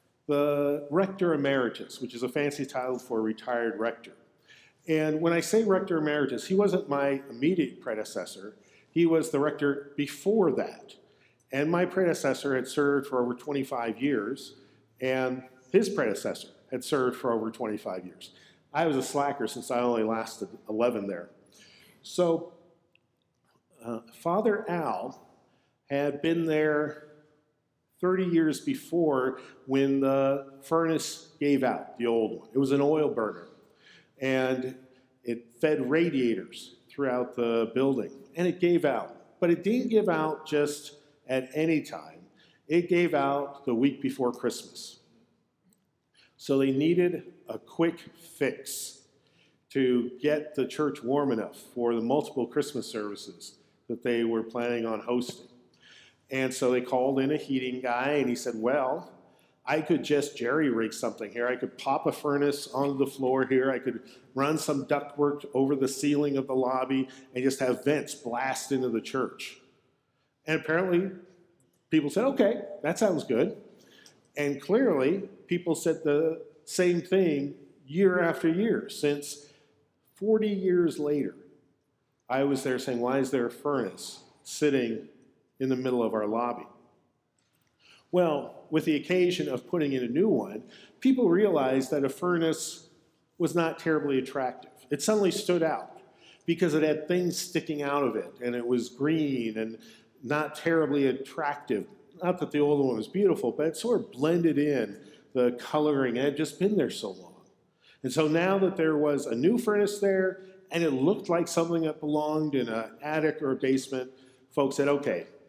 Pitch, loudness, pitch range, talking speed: 145 Hz, -28 LUFS, 130-160 Hz, 155 wpm